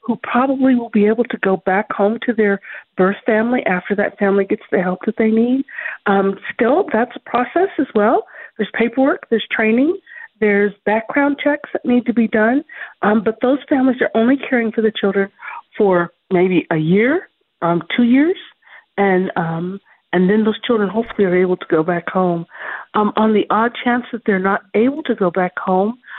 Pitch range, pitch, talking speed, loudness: 195-245 Hz, 220 Hz, 190 wpm, -17 LUFS